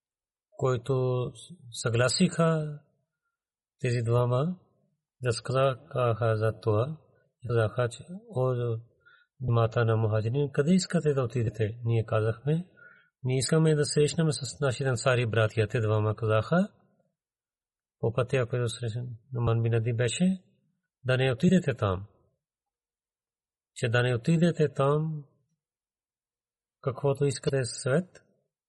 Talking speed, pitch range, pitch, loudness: 90 wpm, 120-155 Hz, 130 Hz, -28 LUFS